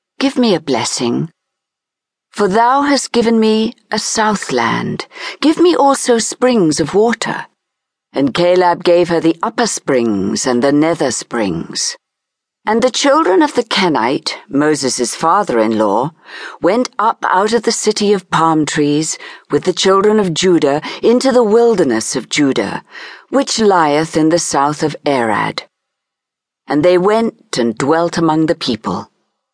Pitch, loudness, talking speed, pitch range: 185 Hz, -14 LUFS, 145 wpm, 155-230 Hz